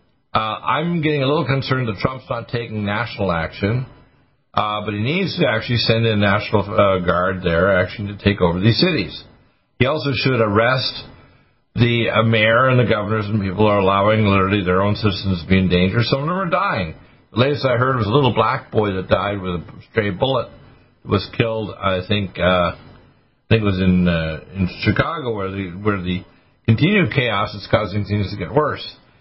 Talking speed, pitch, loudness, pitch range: 205 wpm, 110 Hz, -18 LUFS, 100-125 Hz